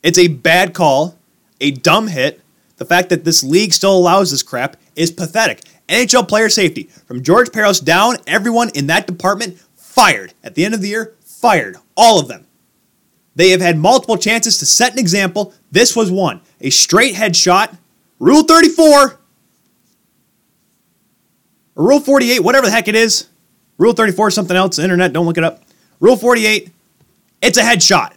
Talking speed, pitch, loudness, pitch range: 170 wpm, 195 Hz, -12 LUFS, 175-225 Hz